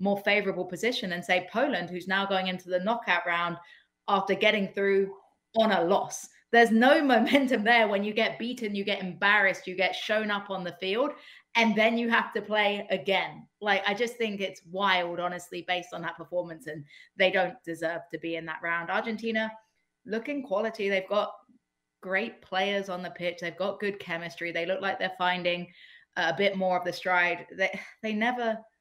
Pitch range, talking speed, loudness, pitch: 180-220 Hz, 190 wpm, -28 LUFS, 195 Hz